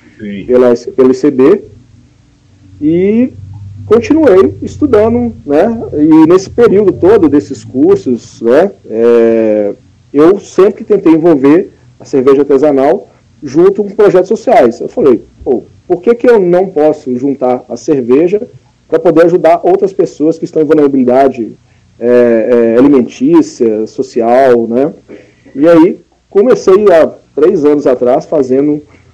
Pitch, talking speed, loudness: 145 Hz, 120 wpm, -9 LUFS